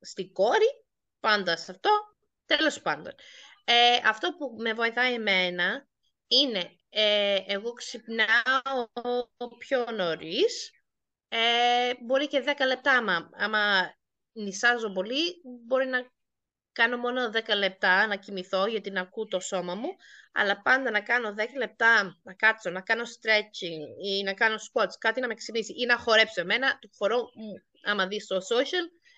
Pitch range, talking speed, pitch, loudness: 200-250 Hz, 145 wpm, 230 Hz, -26 LUFS